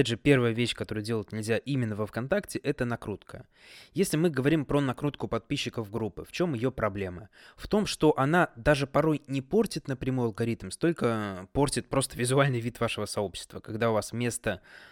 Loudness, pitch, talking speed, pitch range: -29 LUFS, 120 Hz, 175 wpm, 110-145 Hz